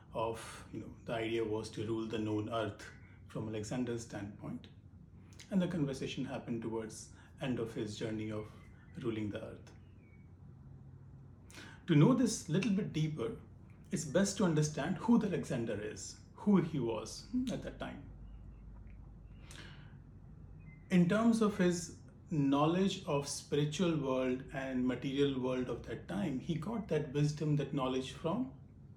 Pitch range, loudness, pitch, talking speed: 115-165 Hz, -36 LUFS, 135 Hz, 140 wpm